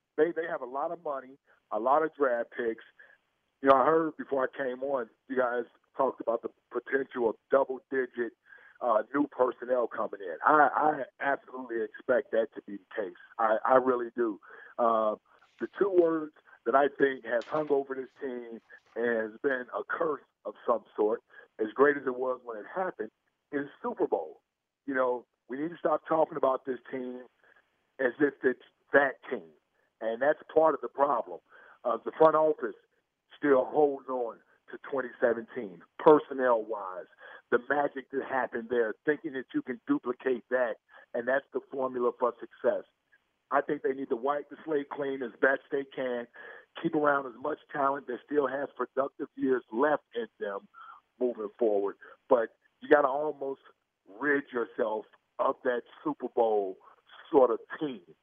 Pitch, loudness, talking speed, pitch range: 135 Hz, -30 LUFS, 175 wpm, 125-150 Hz